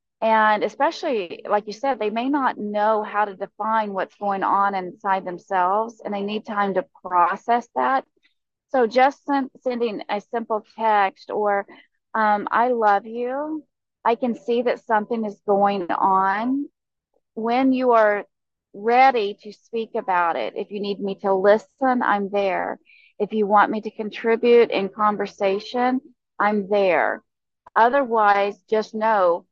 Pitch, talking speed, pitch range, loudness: 215 Hz, 150 wpm, 200-235 Hz, -21 LUFS